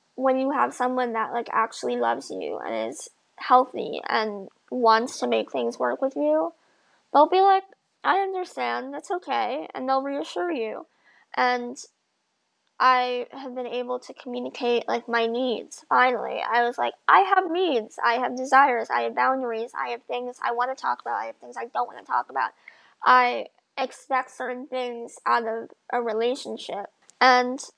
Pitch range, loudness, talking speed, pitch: 235-275 Hz, -24 LUFS, 175 wpm, 250 Hz